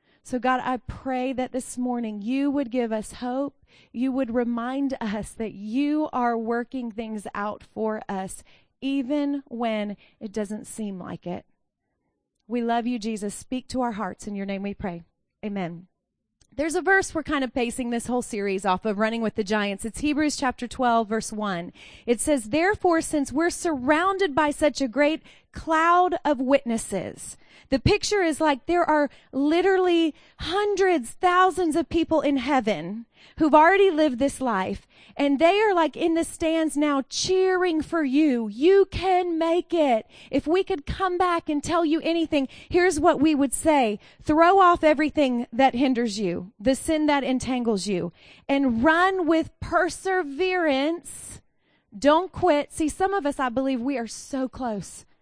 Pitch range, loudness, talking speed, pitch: 235-325 Hz, -24 LUFS, 175 wpm, 275 Hz